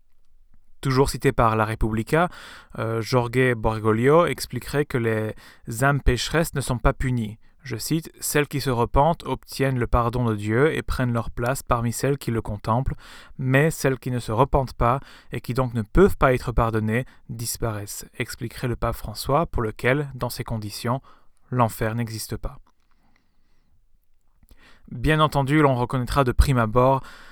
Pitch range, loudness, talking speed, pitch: 115-135 Hz, -23 LUFS, 160 wpm, 125 Hz